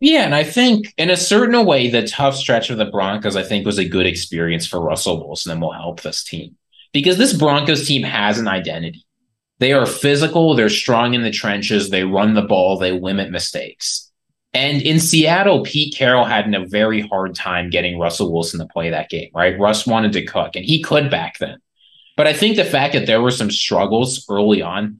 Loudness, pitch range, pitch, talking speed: -16 LUFS, 95-145 Hz, 110 Hz, 215 wpm